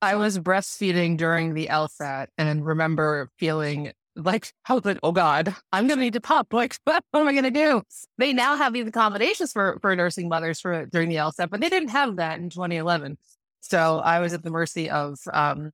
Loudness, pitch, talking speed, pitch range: -24 LUFS, 175 Hz, 210 wpm, 160-240 Hz